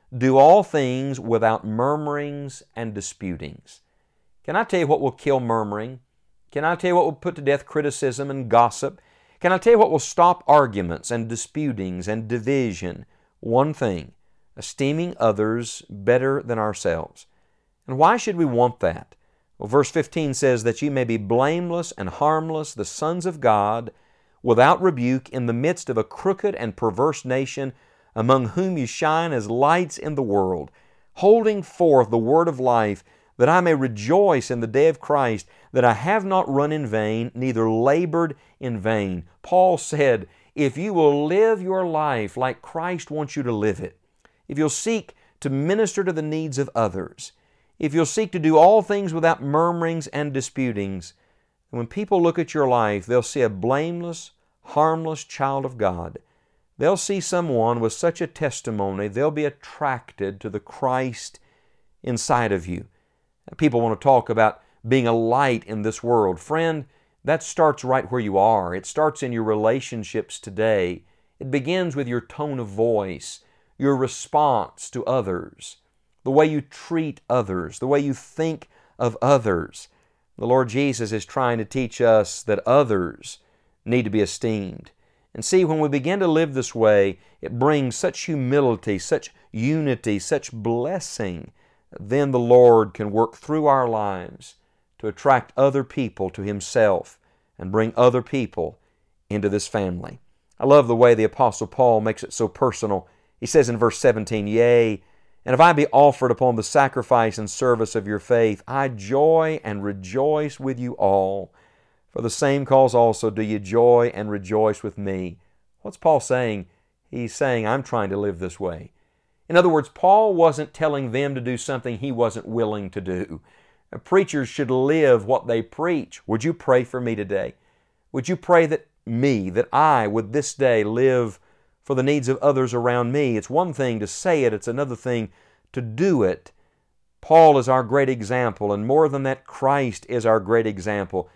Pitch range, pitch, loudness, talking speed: 110-150 Hz, 130 Hz, -21 LUFS, 175 wpm